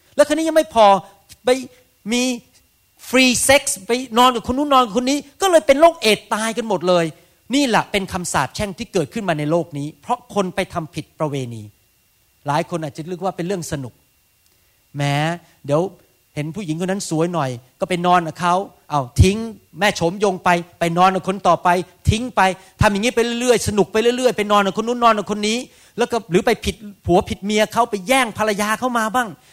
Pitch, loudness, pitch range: 195 Hz, -18 LUFS, 170-235 Hz